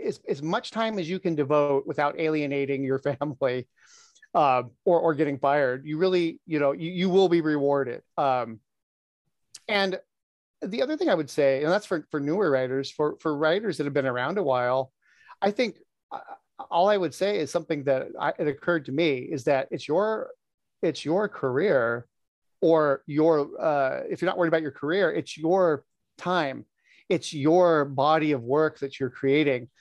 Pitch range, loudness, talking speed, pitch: 140-175 Hz, -25 LUFS, 185 wpm, 155 Hz